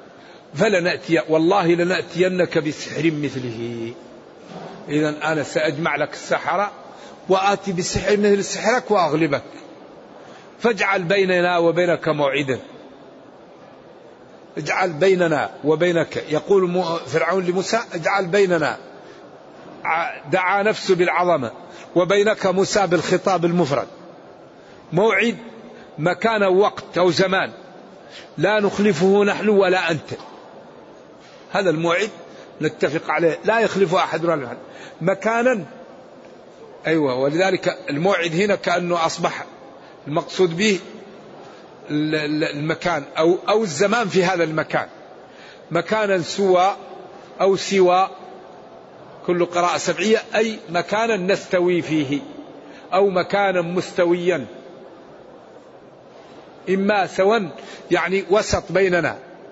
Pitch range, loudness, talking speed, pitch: 165-195 Hz, -20 LUFS, 90 wpm, 180 Hz